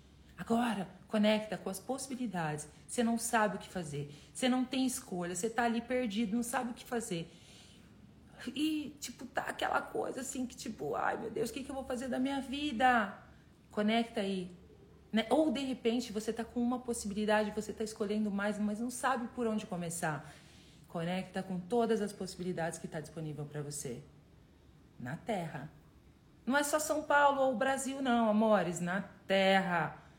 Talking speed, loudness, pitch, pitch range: 175 wpm, -35 LUFS, 220 Hz, 180-250 Hz